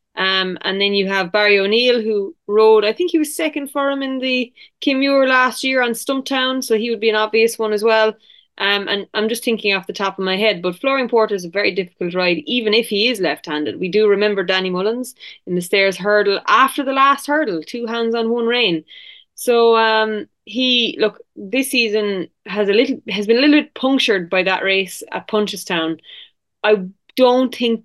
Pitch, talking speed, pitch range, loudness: 220 Hz, 210 wpm, 200-250 Hz, -17 LUFS